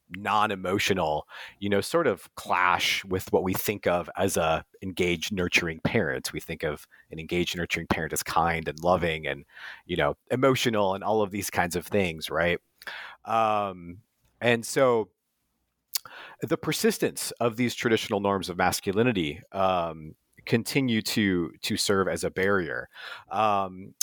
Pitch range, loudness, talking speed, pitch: 90-110 Hz, -27 LUFS, 145 wpm, 100 Hz